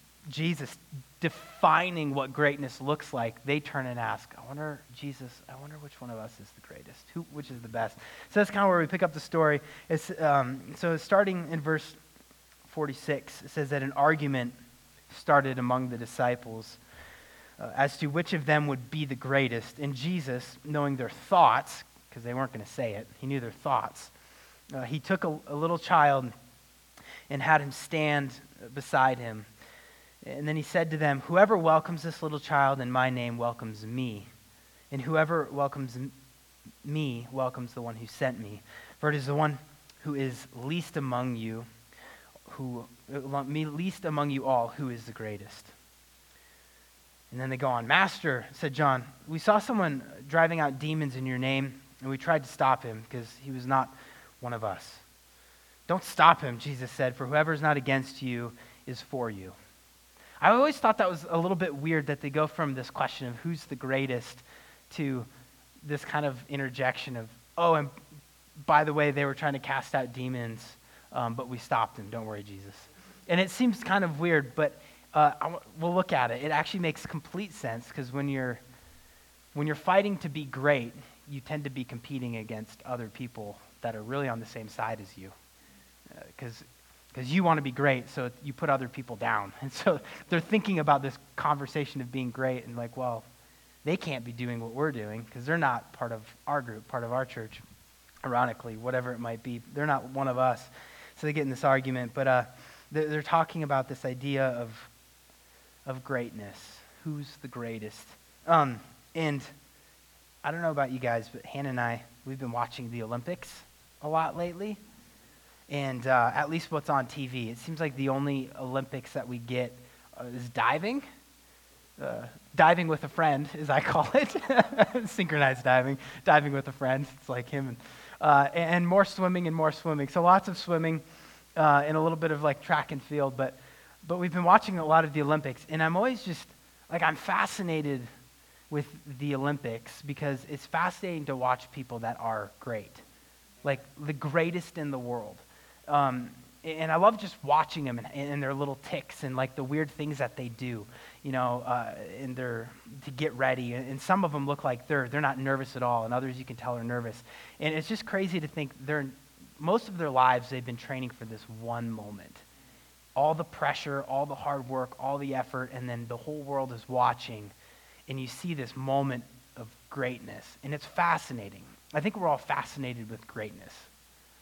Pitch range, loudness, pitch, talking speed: 120-155 Hz, -30 LUFS, 135 Hz, 190 wpm